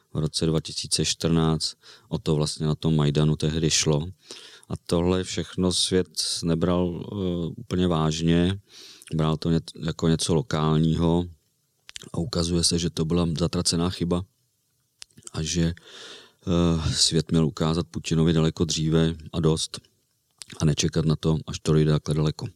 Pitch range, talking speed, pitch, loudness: 80-85 Hz, 140 wpm, 80 Hz, -24 LUFS